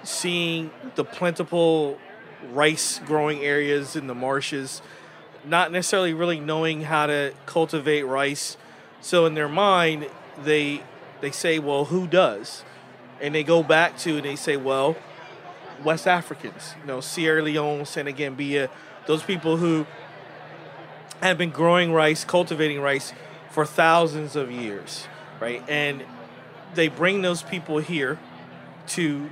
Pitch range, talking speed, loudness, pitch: 145-170 Hz, 130 wpm, -23 LUFS, 155 Hz